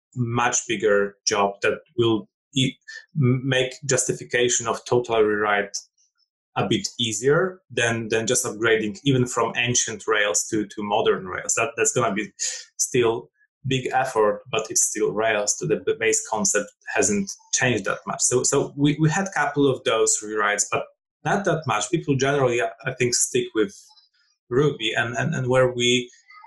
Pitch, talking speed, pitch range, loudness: 130 Hz, 165 wpm, 115-195 Hz, -22 LUFS